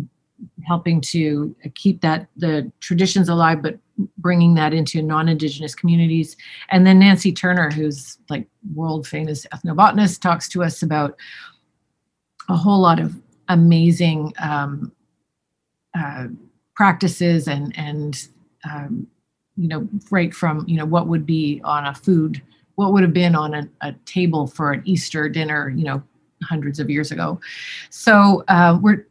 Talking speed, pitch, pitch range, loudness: 145 wpm, 165 Hz, 150-180 Hz, -18 LUFS